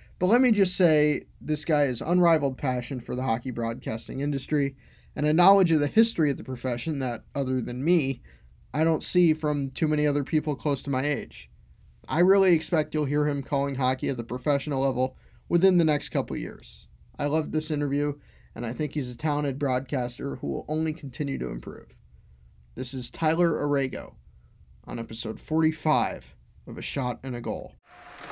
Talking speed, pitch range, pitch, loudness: 185 wpm, 130-155 Hz, 145 Hz, -26 LUFS